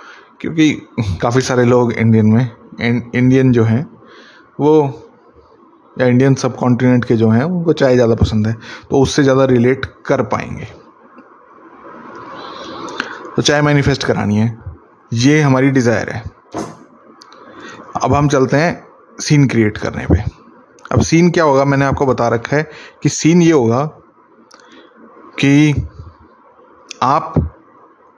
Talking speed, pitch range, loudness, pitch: 130 wpm, 115-145 Hz, -14 LUFS, 130 Hz